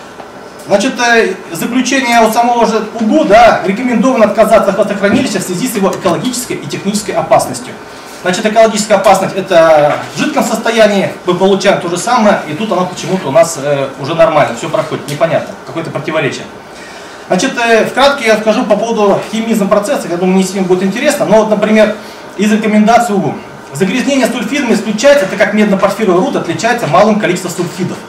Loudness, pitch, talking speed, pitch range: -11 LUFS, 210 Hz, 160 wpm, 190-235 Hz